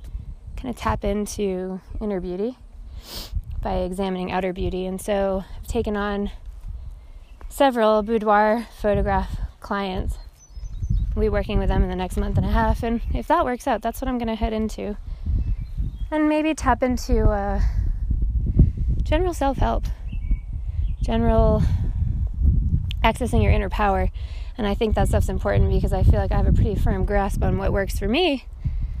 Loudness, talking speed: -23 LUFS, 155 wpm